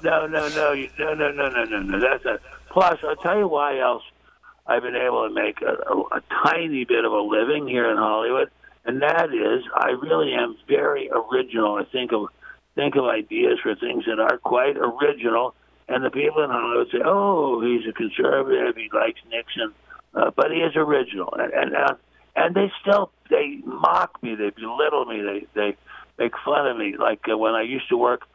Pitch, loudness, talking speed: 195 Hz, -22 LUFS, 200 wpm